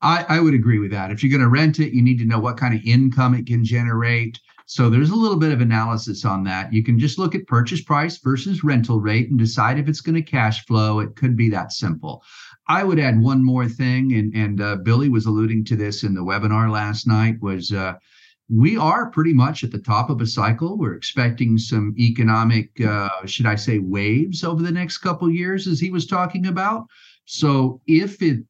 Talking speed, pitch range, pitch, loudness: 230 wpm, 110-155 Hz, 120 Hz, -19 LUFS